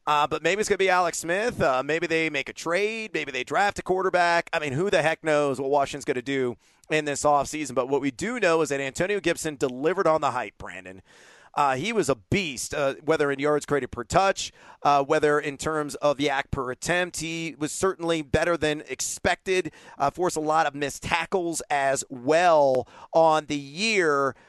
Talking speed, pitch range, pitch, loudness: 210 wpm, 140-170 Hz, 150 Hz, -25 LUFS